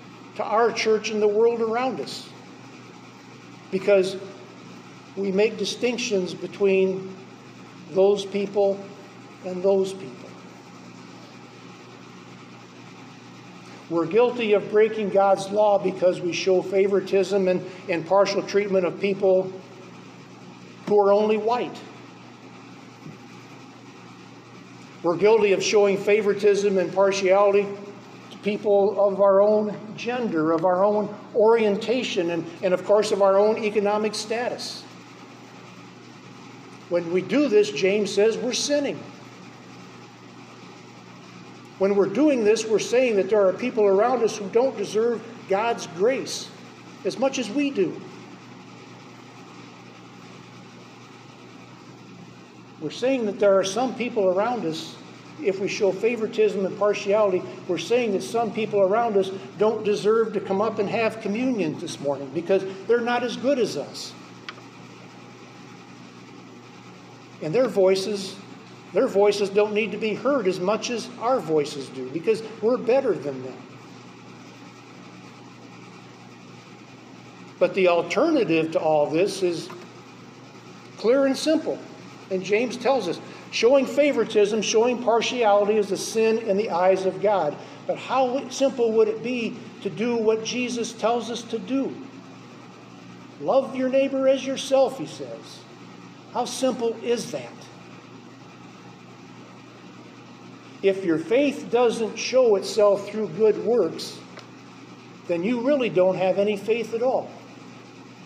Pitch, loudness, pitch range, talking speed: 200 Hz, -23 LUFS, 170-225 Hz, 125 wpm